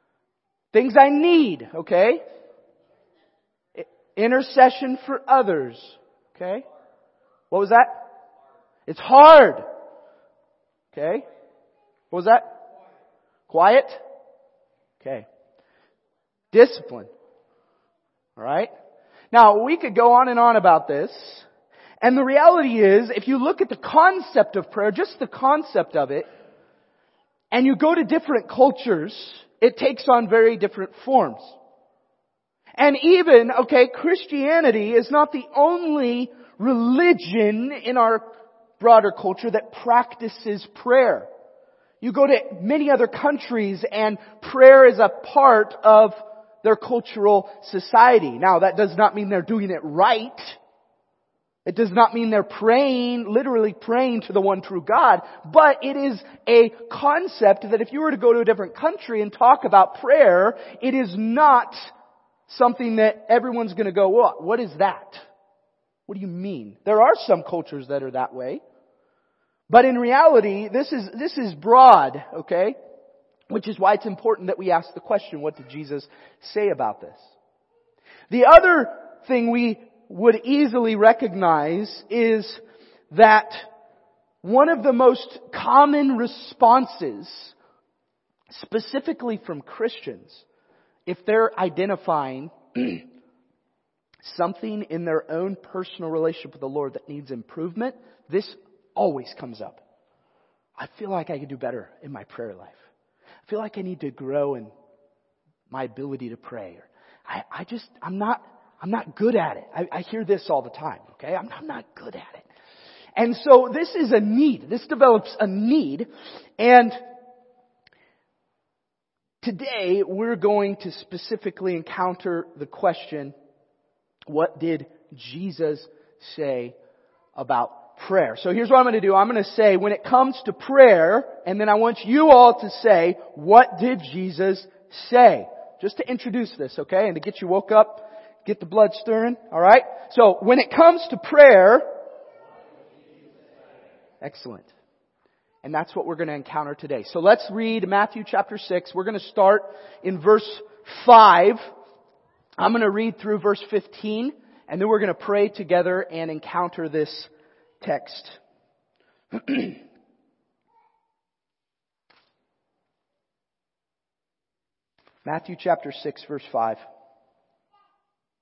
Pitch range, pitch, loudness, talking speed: 195-270 Hz, 225 Hz, -18 LUFS, 135 wpm